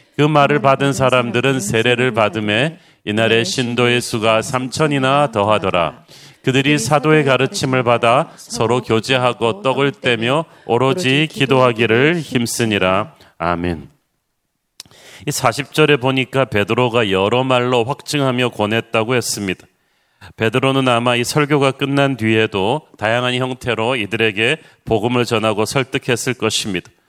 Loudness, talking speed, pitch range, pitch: -16 LUFS, 290 characters per minute, 115-135 Hz, 125 Hz